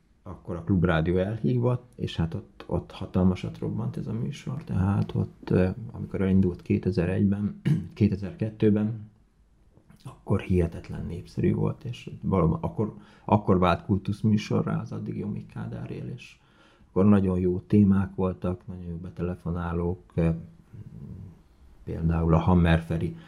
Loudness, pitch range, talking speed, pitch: -27 LUFS, 90-105 Hz, 115 wpm, 95 Hz